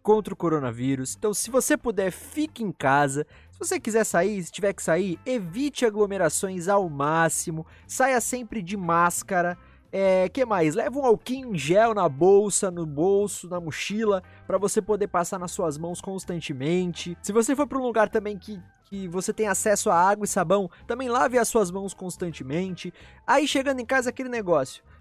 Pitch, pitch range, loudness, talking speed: 195 Hz, 175-225 Hz, -25 LUFS, 180 wpm